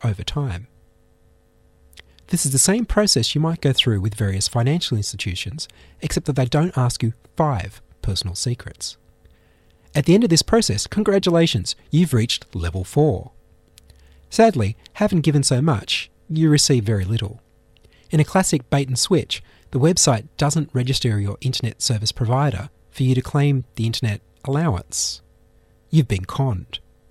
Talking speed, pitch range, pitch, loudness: 150 wpm, 100-150 Hz, 125 Hz, -20 LUFS